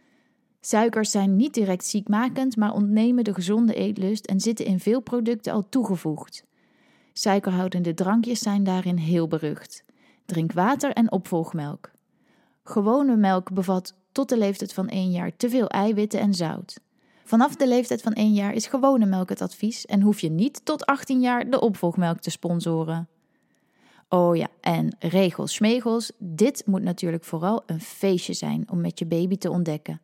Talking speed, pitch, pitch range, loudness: 160 wpm, 205 Hz, 180-235 Hz, -24 LUFS